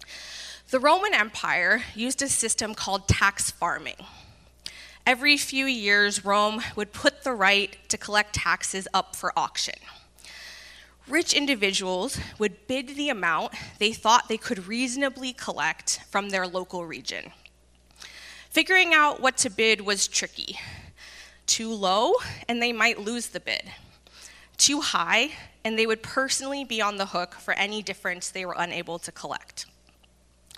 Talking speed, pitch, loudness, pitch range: 140 wpm, 215 Hz, -24 LUFS, 190-265 Hz